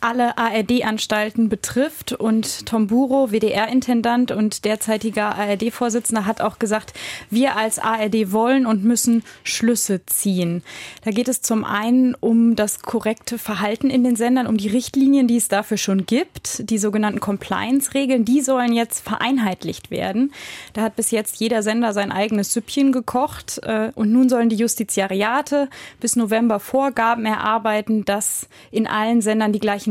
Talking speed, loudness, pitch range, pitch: 150 wpm, -19 LUFS, 215-245 Hz, 225 Hz